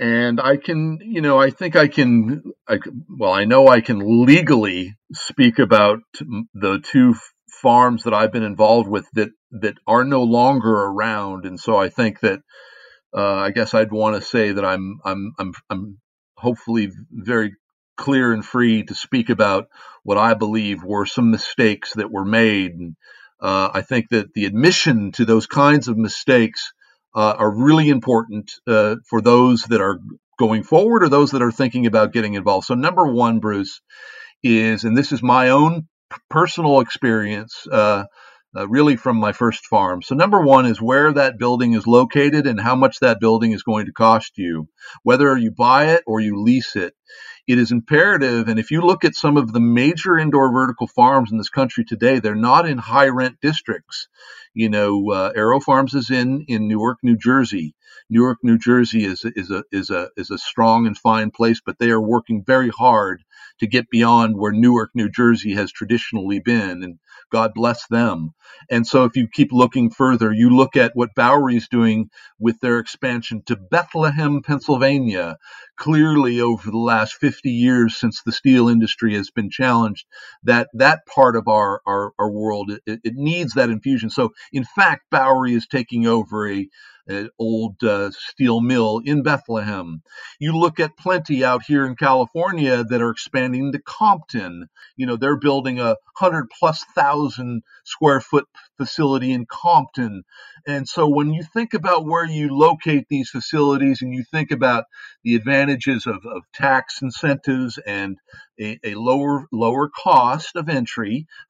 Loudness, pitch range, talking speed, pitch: -17 LUFS, 110-140 Hz, 175 wpm, 120 Hz